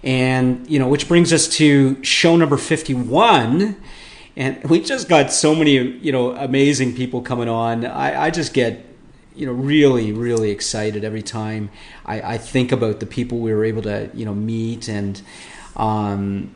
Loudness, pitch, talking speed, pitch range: -18 LUFS, 125 Hz, 175 wpm, 110-145 Hz